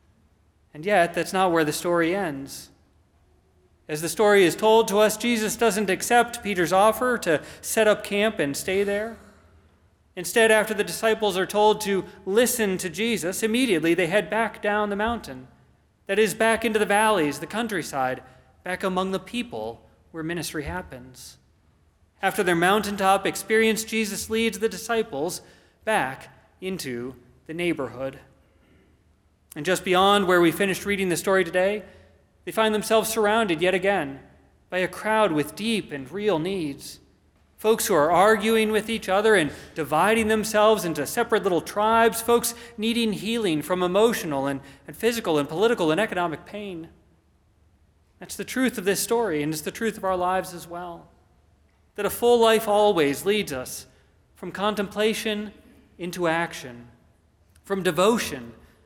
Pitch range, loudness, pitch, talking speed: 140-215 Hz, -23 LUFS, 185 Hz, 155 wpm